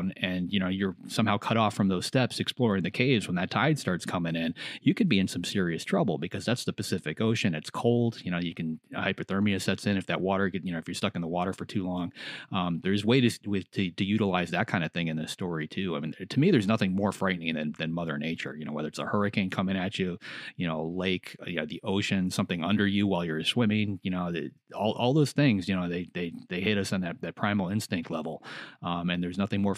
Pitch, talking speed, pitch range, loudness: 95 Hz, 260 wpm, 85-100 Hz, -29 LUFS